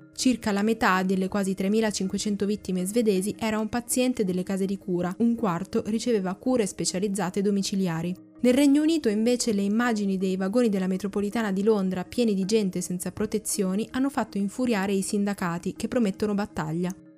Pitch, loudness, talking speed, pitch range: 205 Hz, -26 LUFS, 160 wpm, 190-225 Hz